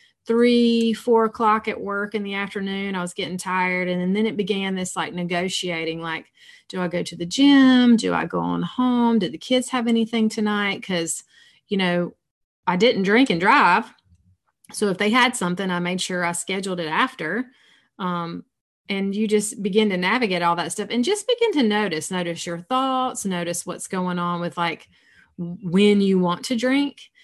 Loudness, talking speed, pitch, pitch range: -21 LUFS, 195 wpm, 200 Hz, 175-230 Hz